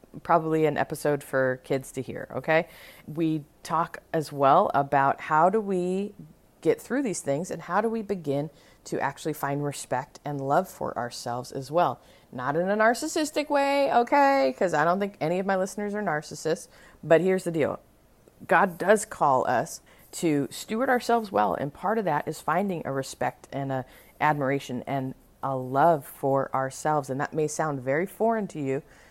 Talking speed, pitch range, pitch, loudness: 180 wpm, 135-190 Hz, 155 Hz, -26 LUFS